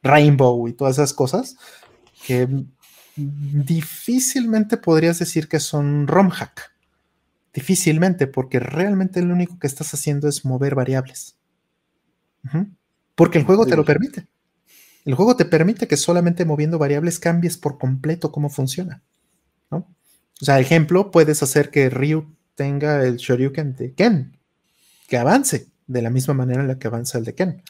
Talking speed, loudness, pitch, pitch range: 150 wpm, -19 LUFS, 150 Hz, 140-175 Hz